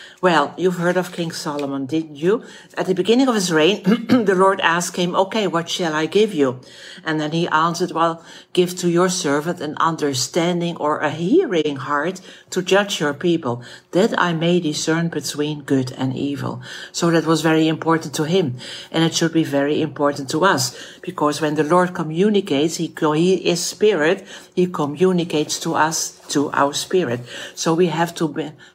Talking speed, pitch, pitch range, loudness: 180 wpm, 165 Hz, 150-180 Hz, -19 LUFS